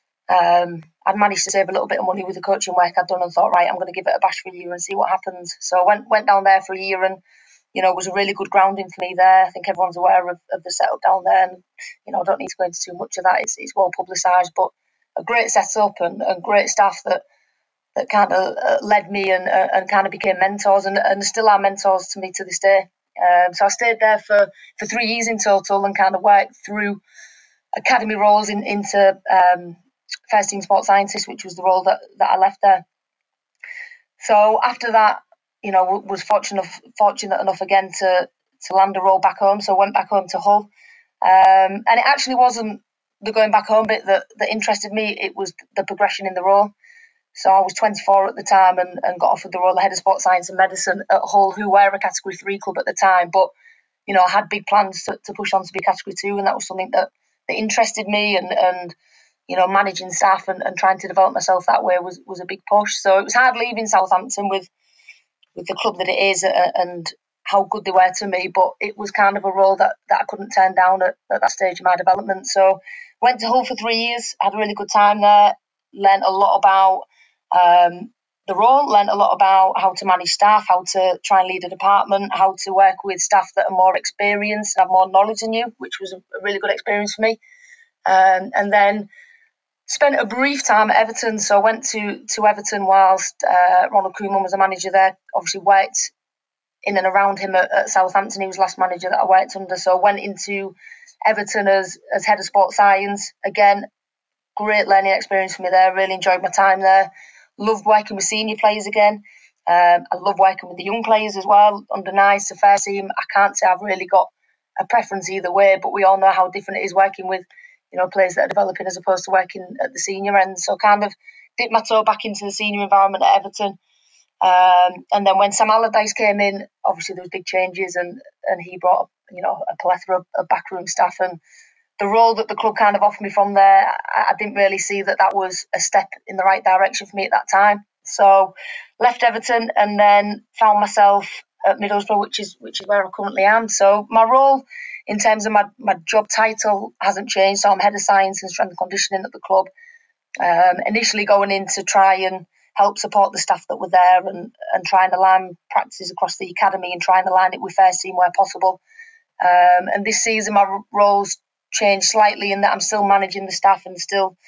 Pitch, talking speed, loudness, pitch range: 195 Hz, 235 wpm, -17 LUFS, 190-210 Hz